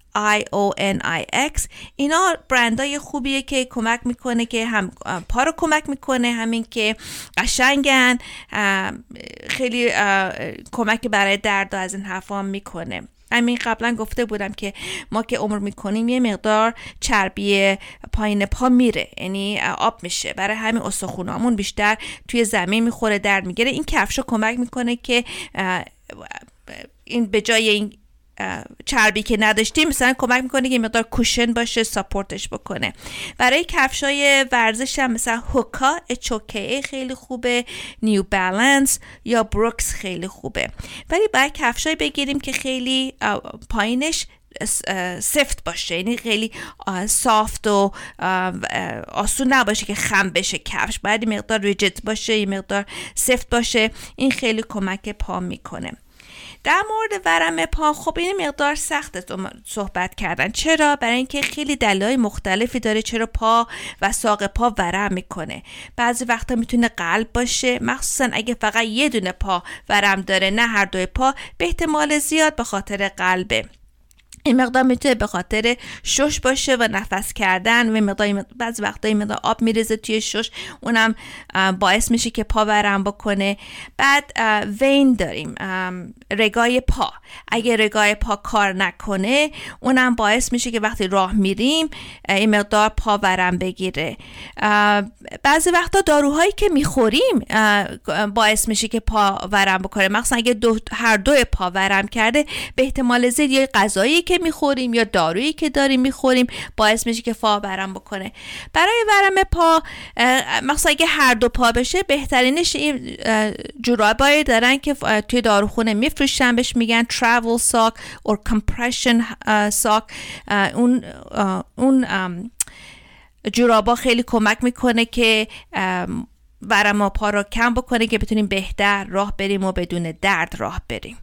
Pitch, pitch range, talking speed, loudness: 230 Hz, 205-255 Hz, 140 wpm, -19 LUFS